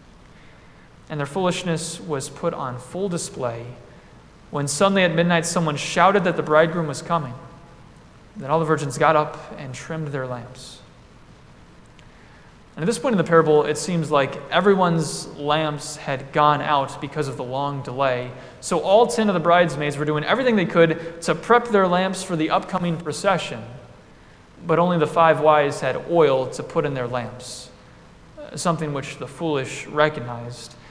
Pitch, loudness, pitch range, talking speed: 155 Hz, -21 LUFS, 140-170 Hz, 165 wpm